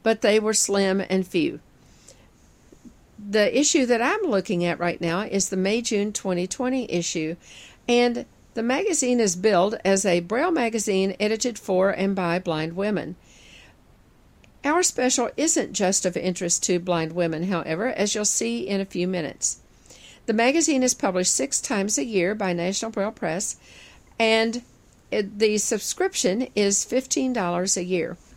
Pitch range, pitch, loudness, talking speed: 180-240 Hz, 200 Hz, -23 LUFS, 150 wpm